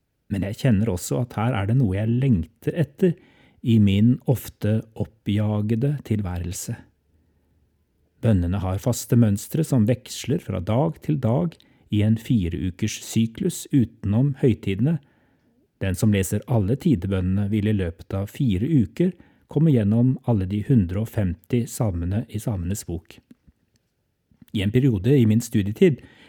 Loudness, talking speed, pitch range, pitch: -23 LUFS, 135 wpm, 100-130 Hz, 110 Hz